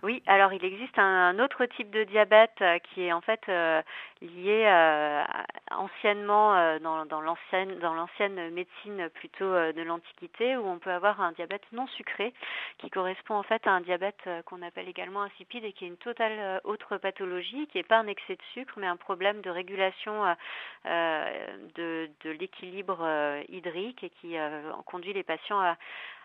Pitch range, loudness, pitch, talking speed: 170-210 Hz, -29 LUFS, 190 Hz, 180 wpm